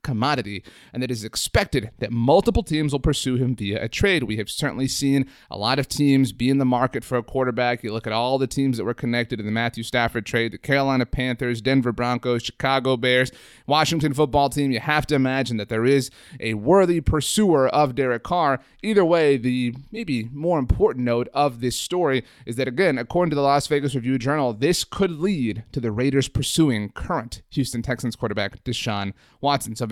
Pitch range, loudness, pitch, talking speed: 120-140 Hz, -22 LUFS, 130 Hz, 200 wpm